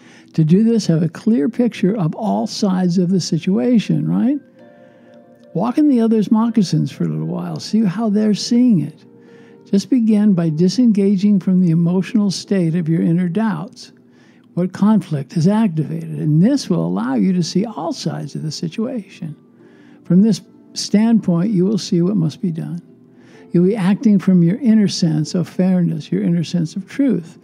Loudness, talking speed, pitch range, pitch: -17 LUFS, 175 wpm, 170-220 Hz, 190 Hz